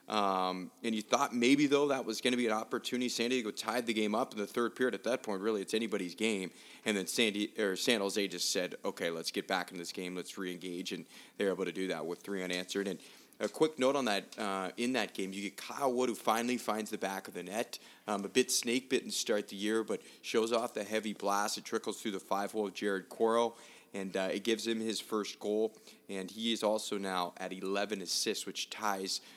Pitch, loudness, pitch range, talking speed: 105 Hz, -34 LUFS, 95-115 Hz, 245 wpm